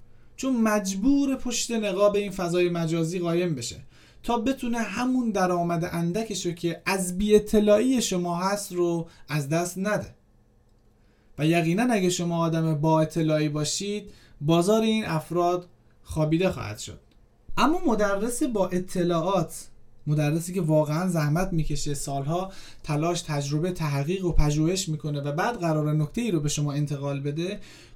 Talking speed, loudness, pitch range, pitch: 140 wpm, -26 LUFS, 150-200 Hz, 170 Hz